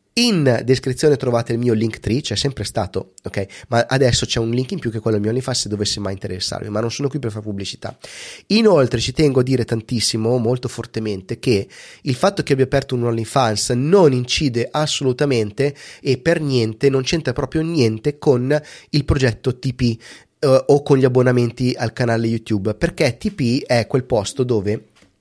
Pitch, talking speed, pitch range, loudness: 125 Hz, 190 wpm, 115-140 Hz, -19 LUFS